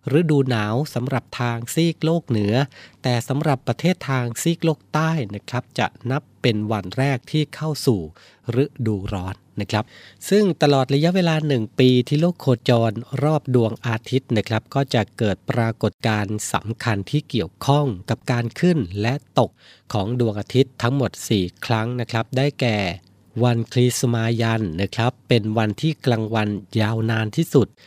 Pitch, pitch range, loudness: 120 Hz, 110-140 Hz, -21 LUFS